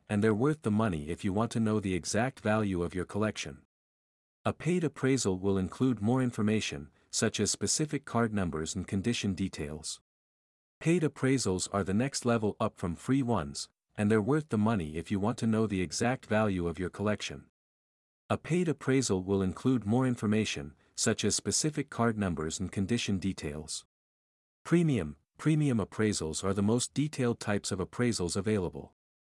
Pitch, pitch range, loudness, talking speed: 105 Hz, 90-120 Hz, -31 LUFS, 170 wpm